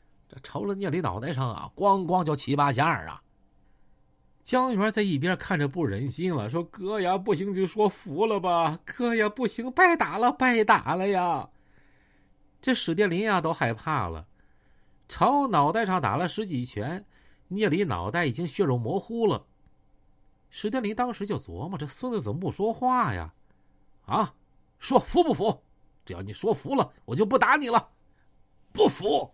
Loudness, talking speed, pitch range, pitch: -26 LUFS, 235 characters per minute, 150-215 Hz, 185 Hz